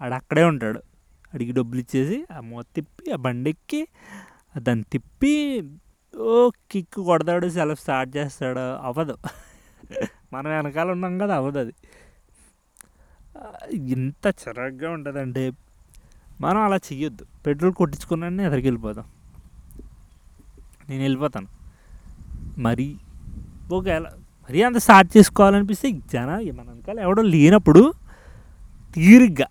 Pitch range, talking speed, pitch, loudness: 125-185 Hz, 105 wpm, 150 Hz, -20 LUFS